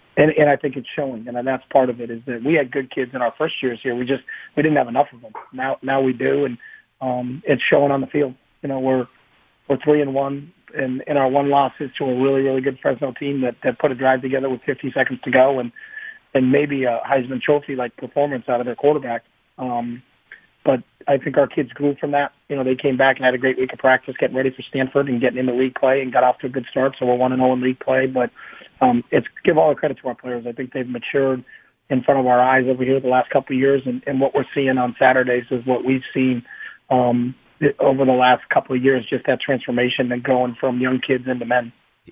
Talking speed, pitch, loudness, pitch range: 265 wpm, 130 Hz, -19 LUFS, 125-140 Hz